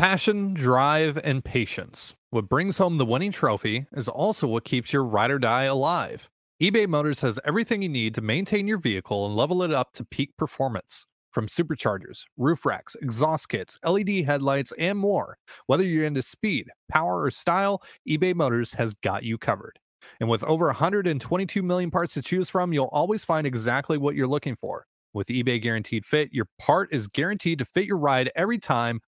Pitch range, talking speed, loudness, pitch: 120-180 Hz, 185 wpm, -25 LUFS, 145 Hz